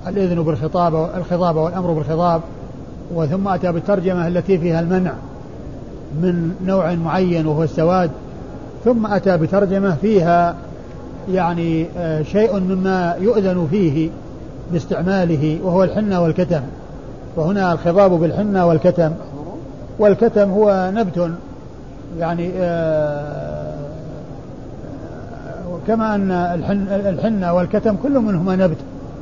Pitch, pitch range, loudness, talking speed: 175 Hz, 165-190 Hz, -18 LUFS, 90 wpm